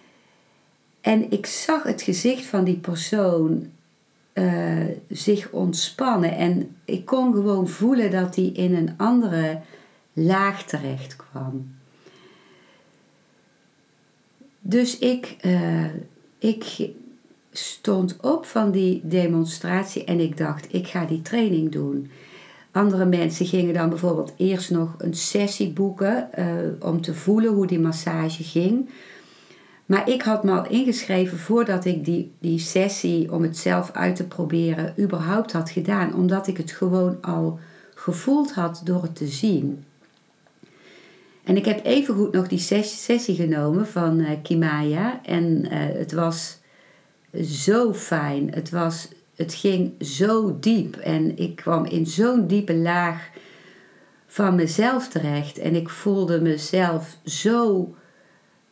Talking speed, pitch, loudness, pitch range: 130 wpm, 180 Hz, -23 LUFS, 165-200 Hz